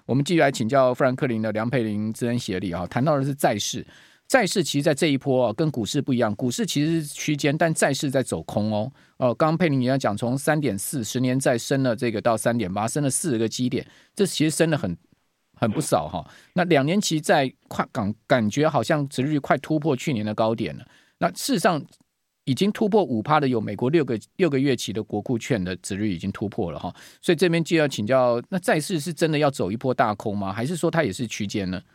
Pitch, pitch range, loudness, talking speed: 130 Hz, 110-155 Hz, -23 LUFS, 345 characters per minute